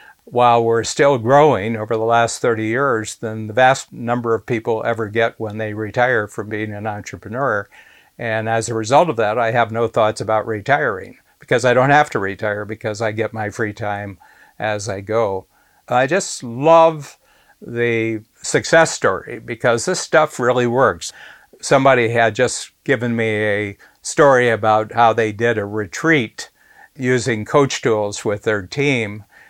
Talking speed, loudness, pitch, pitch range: 165 wpm, -17 LUFS, 115 Hz, 110-125 Hz